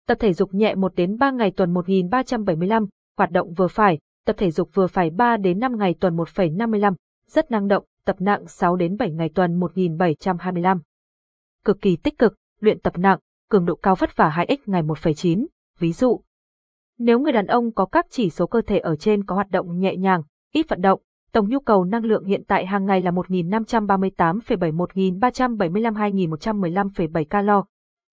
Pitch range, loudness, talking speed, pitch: 180-220 Hz, -21 LUFS, 185 wpm, 195 Hz